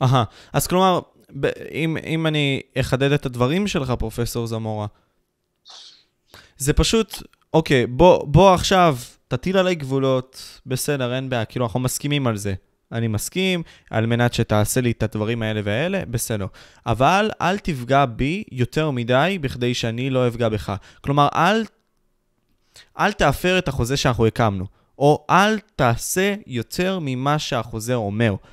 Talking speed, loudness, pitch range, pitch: 140 wpm, -20 LUFS, 115-160 Hz, 130 Hz